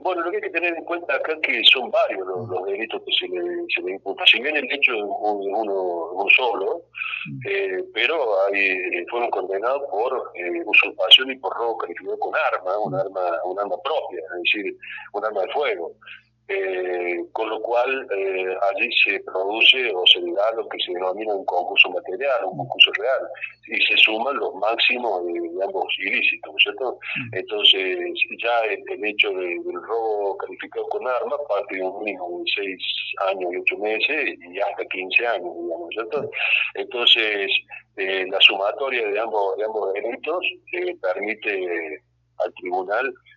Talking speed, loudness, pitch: 180 wpm, -21 LUFS, 370 Hz